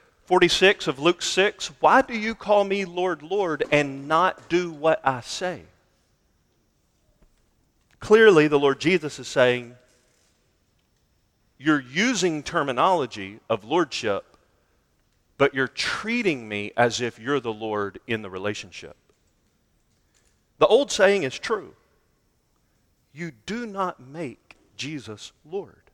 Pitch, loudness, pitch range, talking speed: 145 Hz, -22 LUFS, 120-185 Hz, 120 wpm